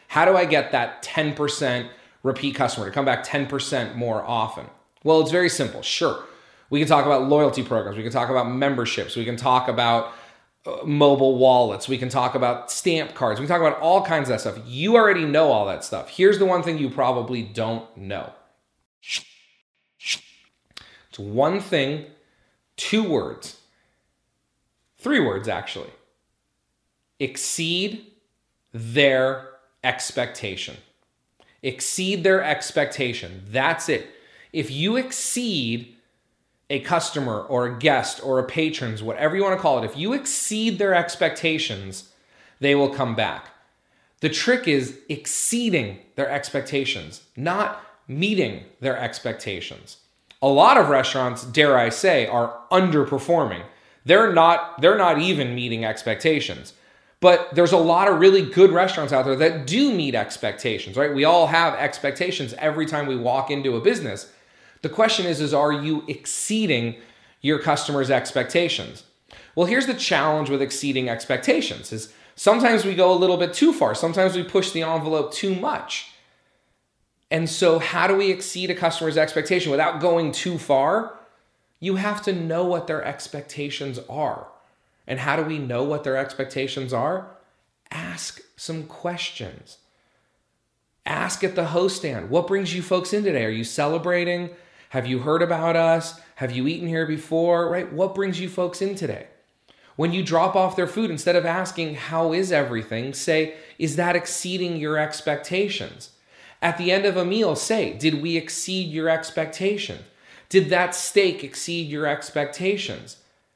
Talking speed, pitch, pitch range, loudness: 155 wpm, 155 Hz, 130-180 Hz, -22 LUFS